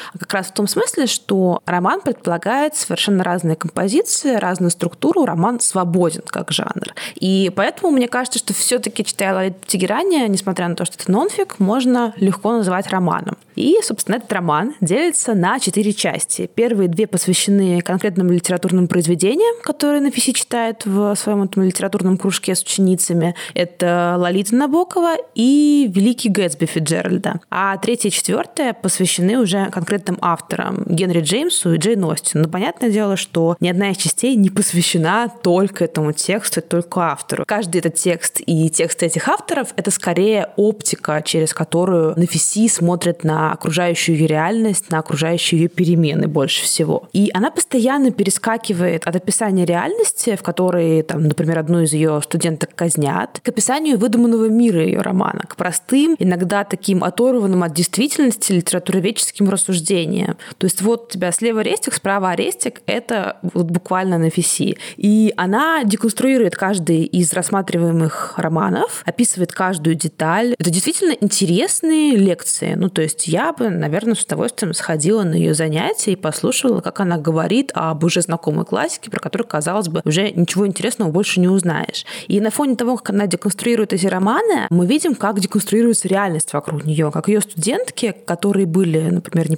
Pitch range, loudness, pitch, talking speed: 175-225 Hz, -17 LUFS, 195 Hz, 155 wpm